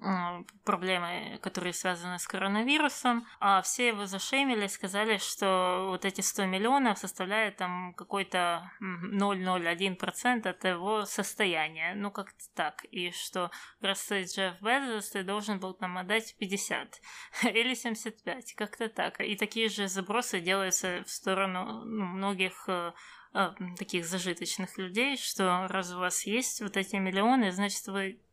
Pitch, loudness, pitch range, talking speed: 195 Hz, -31 LUFS, 185-215 Hz, 135 wpm